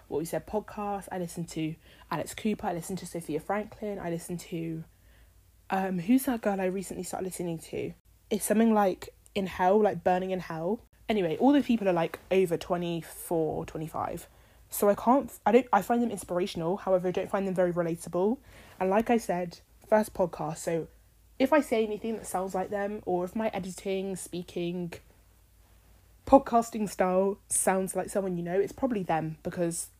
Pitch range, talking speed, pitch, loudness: 175-210 Hz, 180 wpm, 185 Hz, -29 LUFS